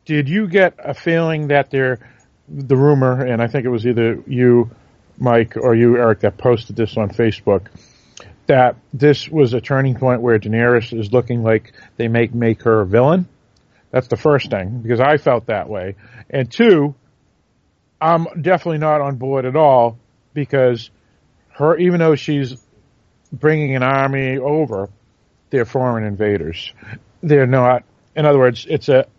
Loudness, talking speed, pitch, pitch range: -16 LUFS, 160 wpm, 125 Hz, 115-145 Hz